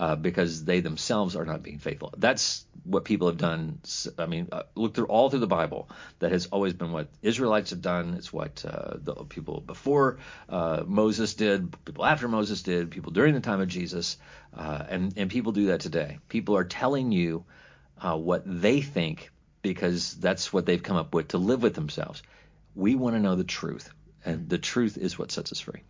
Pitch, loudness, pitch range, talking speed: 95 Hz, -28 LUFS, 85-110 Hz, 205 wpm